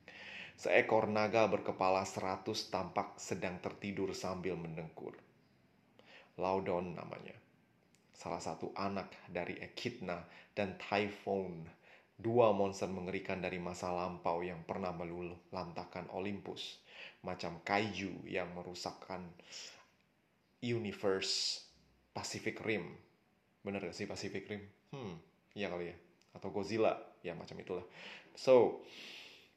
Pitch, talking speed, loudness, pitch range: 95 Hz, 100 wpm, -38 LUFS, 90-100 Hz